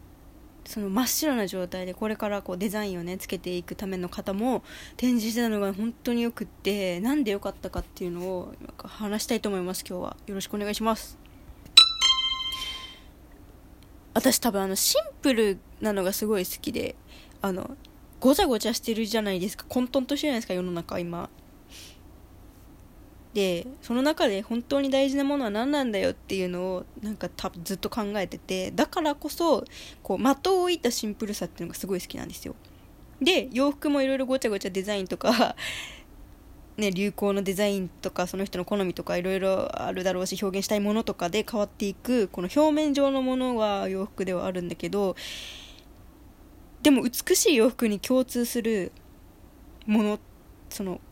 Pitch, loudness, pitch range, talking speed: 210 Hz, -26 LUFS, 190-255 Hz, 355 characters per minute